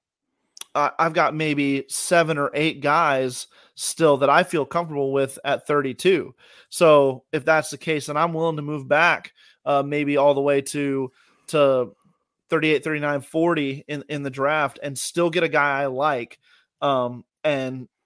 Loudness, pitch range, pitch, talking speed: -21 LUFS, 140-160 Hz, 145 Hz, 165 wpm